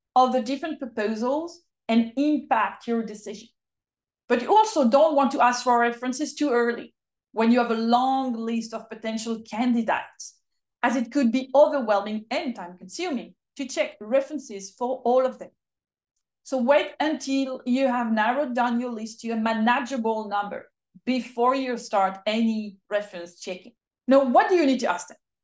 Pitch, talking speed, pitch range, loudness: 245 Hz, 165 wpm, 225-270 Hz, -24 LUFS